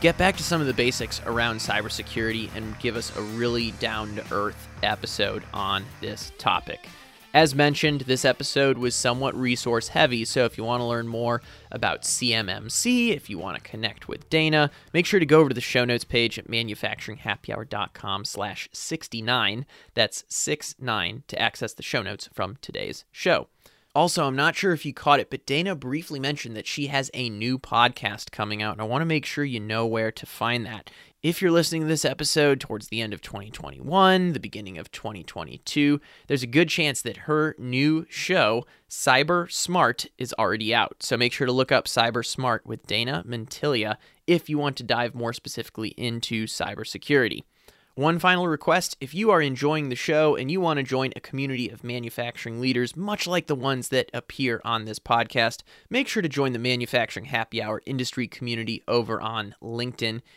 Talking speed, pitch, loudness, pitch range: 190 wpm, 125 Hz, -25 LUFS, 115-150 Hz